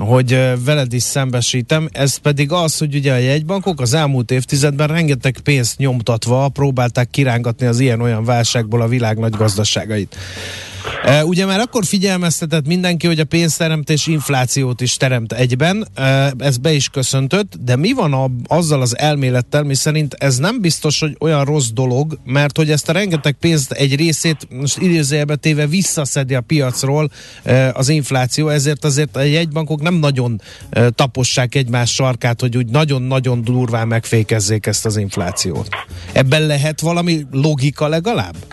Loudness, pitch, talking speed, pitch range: -15 LUFS, 140 Hz, 155 wpm, 125-155 Hz